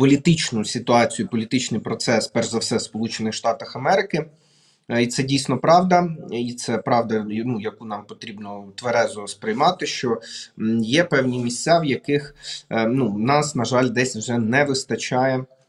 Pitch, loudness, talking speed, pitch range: 125 Hz, -21 LUFS, 140 wpm, 115-145 Hz